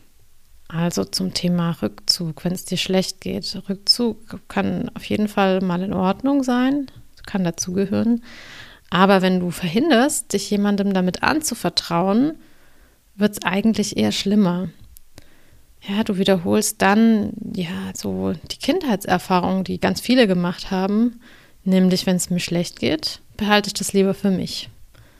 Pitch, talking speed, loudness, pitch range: 195 Hz, 140 wpm, -20 LUFS, 180-210 Hz